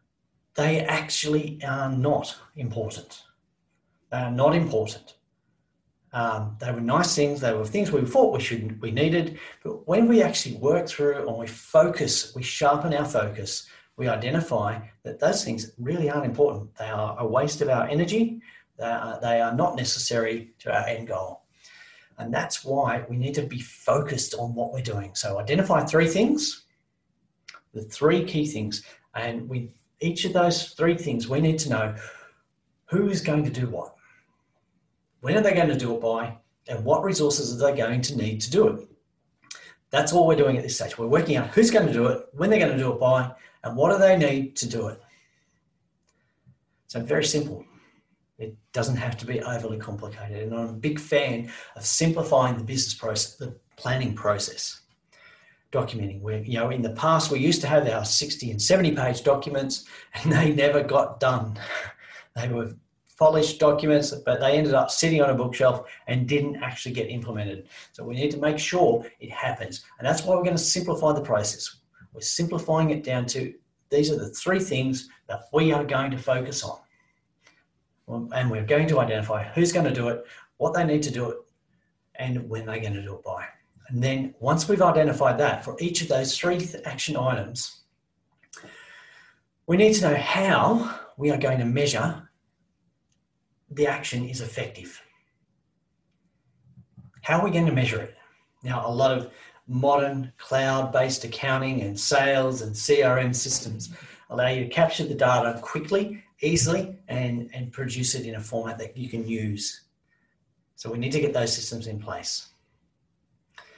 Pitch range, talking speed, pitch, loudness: 115-155 Hz, 180 wpm, 135 Hz, -25 LUFS